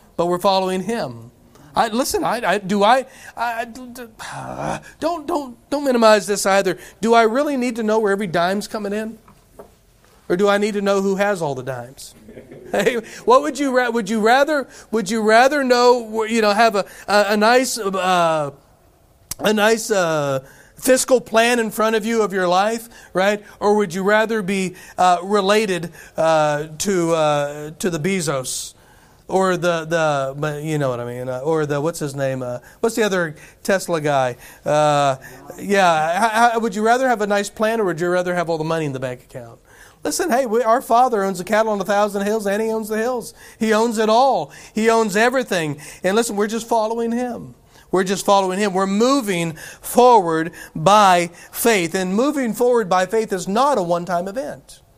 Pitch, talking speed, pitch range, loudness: 205 Hz, 190 wpm, 170-230 Hz, -18 LUFS